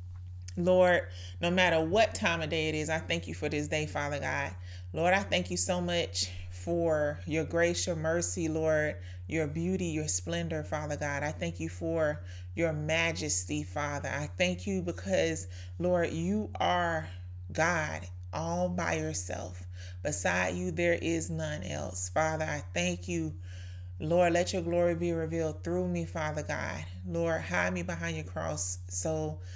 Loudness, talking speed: -31 LUFS, 160 wpm